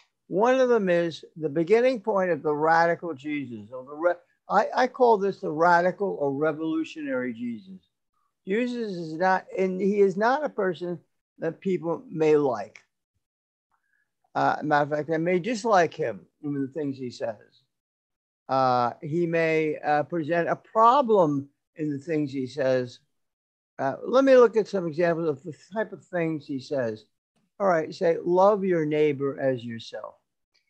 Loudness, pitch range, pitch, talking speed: -25 LUFS, 145-195 Hz, 165 Hz, 160 wpm